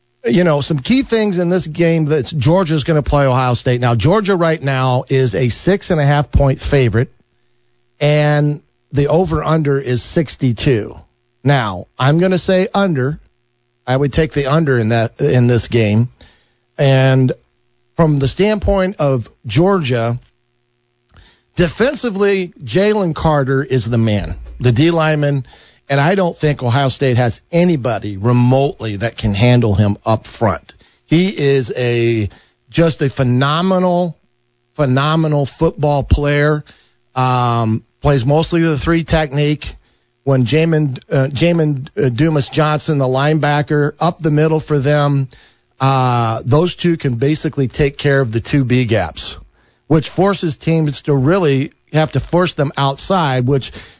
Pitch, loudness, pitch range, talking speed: 140 Hz, -15 LUFS, 120-160 Hz, 140 wpm